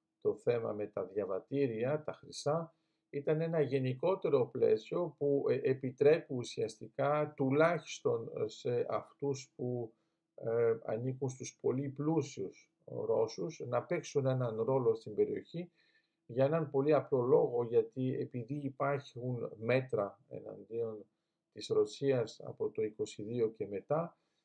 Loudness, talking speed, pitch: -35 LUFS, 115 wpm, 155 Hz